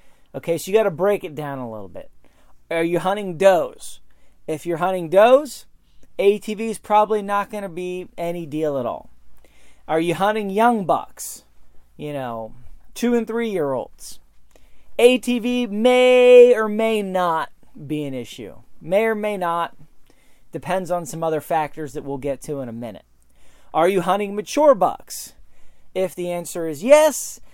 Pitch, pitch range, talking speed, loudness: 175 Hz, 145-210 Hz, 165 wpm, -20 LUFS